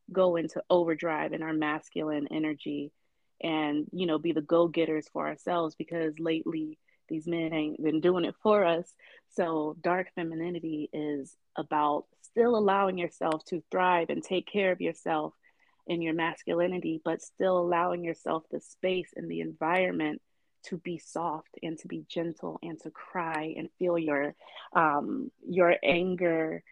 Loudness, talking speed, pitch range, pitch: -30 LUFS, 155 wpm, 155-180 Hz, 165 Hz